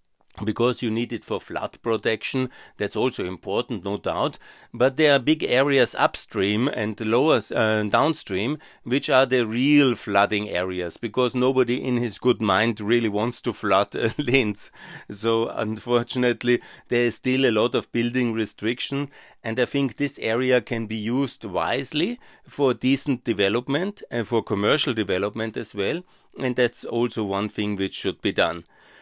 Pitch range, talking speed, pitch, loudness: 110-130 Hz, 160 wpm, 120 Hz, -23 LUFS